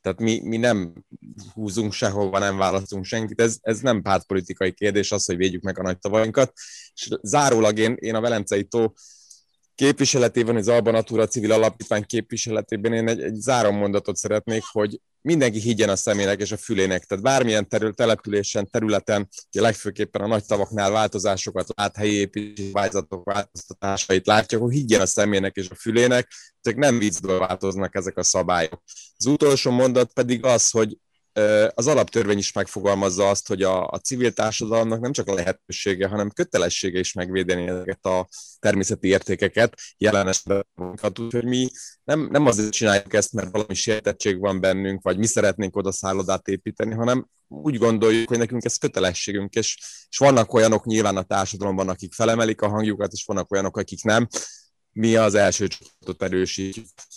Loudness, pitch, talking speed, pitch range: -22 LUFS, 105 Hz, 160 wpm, 95-115 Hz